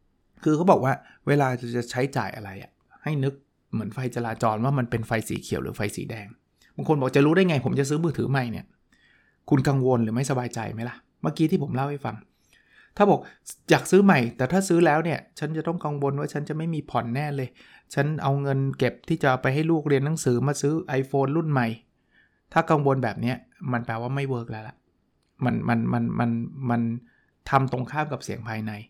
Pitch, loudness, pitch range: 135 Hz, -25 LUFS, 120-150 Hz